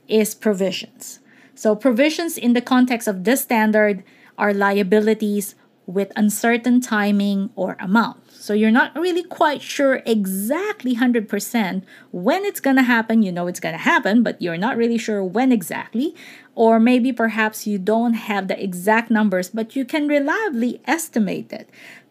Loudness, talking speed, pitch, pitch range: -19 LUFS, 150 wpm, 225 Hz, 210-255 Hz